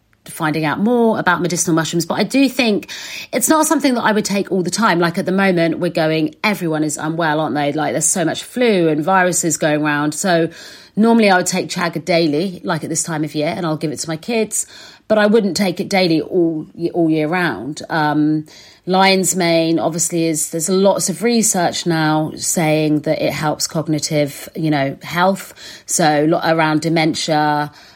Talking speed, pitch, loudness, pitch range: 195 wpm, 170 Hz, -16 LUFS, 155-190 Hz